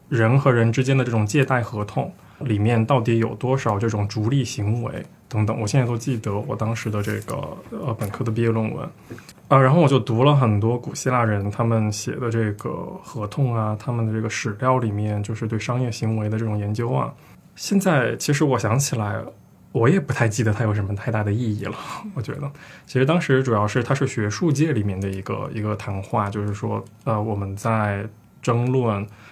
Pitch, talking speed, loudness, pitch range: 115 Hz, 305 characters per minute, -22 LUFS, 105-130 Hz